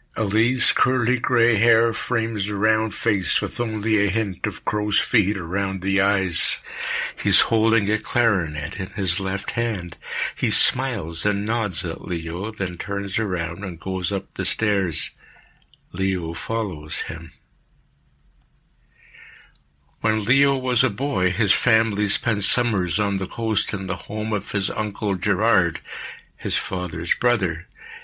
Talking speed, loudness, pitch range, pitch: 140 wpm, -22 LUFS, 95-115 Hz, 105 Hz